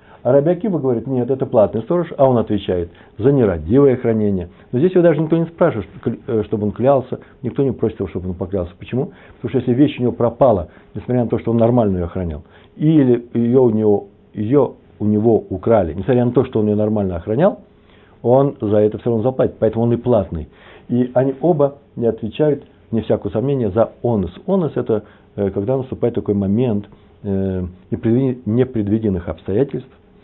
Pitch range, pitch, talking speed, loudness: 100-130 Hz, 115 Hz, 180 wpm, -18 LUFS